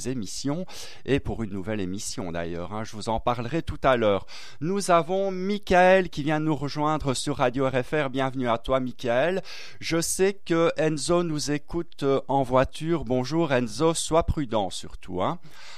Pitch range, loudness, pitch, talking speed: 125-165 Hz, -26 LUFS, 145 Hz, 165 wpm